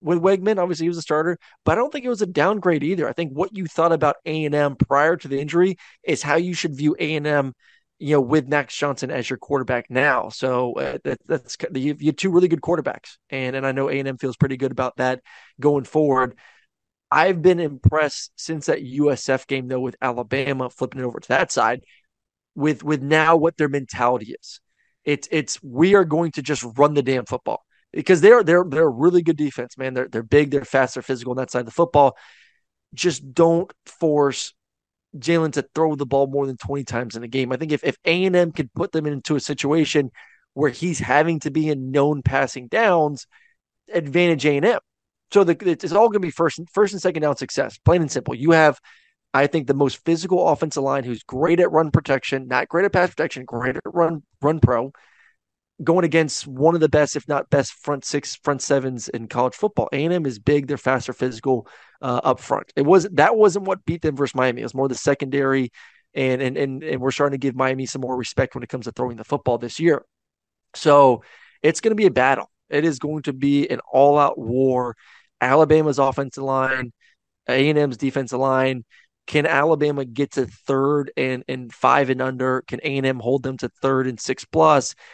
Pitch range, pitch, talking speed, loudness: 130-160 Hz, 145 Hz, 215 wpm, -20 LUFS